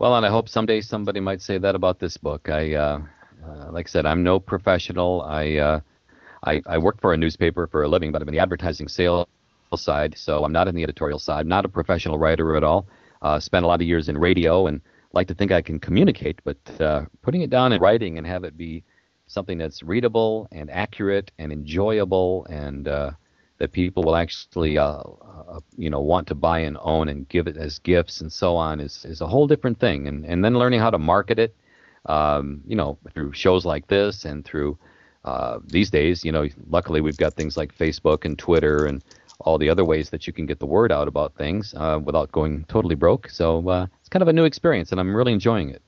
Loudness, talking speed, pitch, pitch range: -22 LUFS, 230 wpm, 85 Hz, 75-95 Hz